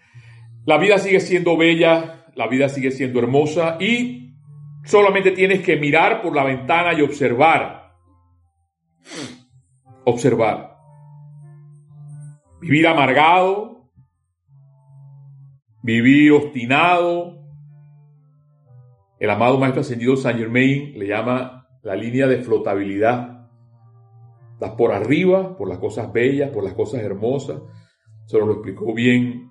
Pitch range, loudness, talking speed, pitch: 120-150 Hz, -17 LUFS, 105 wpm, 140 Hz